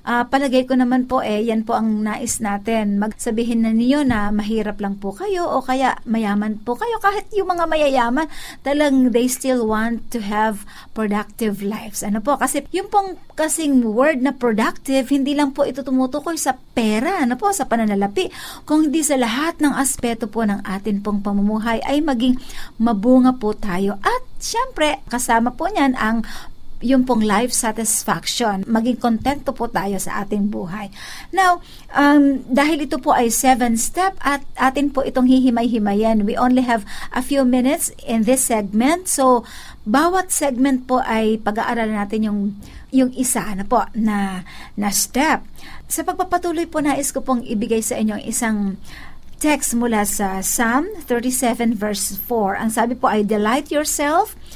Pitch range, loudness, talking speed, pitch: 220-280 Hz, -19 LUFS, 165 wpm, 245 Hz